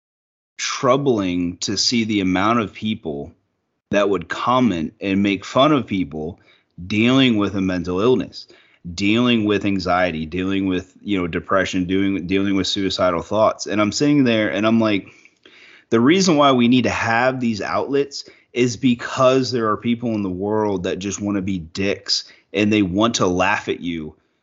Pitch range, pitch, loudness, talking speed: 95-115 Hz, 100 Hz, -19 LUFS, 170 wpm